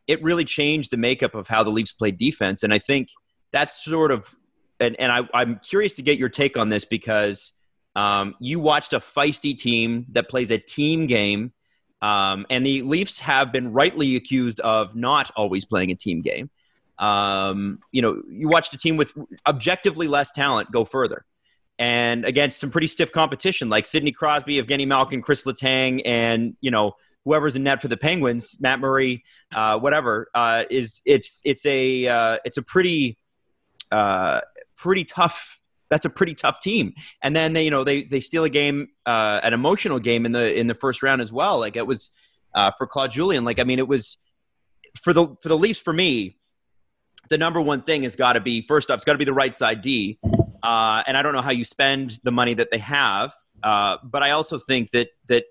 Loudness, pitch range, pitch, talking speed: -21 LUFS, 115-150 Hz, 135 Hz, 200 wpm